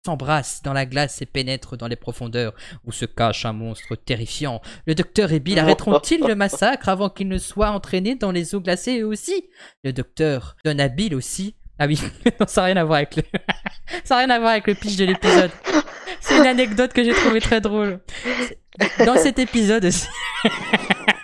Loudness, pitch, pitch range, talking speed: -20 LUFS, 190 Hz, 145-225 Hz, 195 wpm